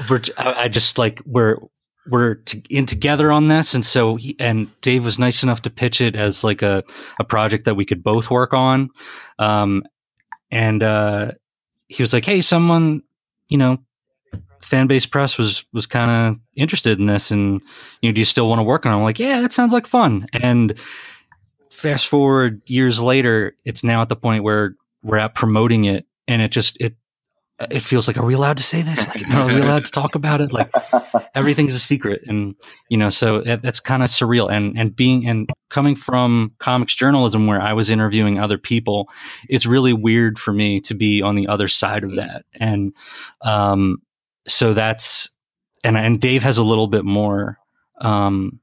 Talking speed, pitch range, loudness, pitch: 195 wpm, 105-130 Hz, -17 LUFS, 115 Hz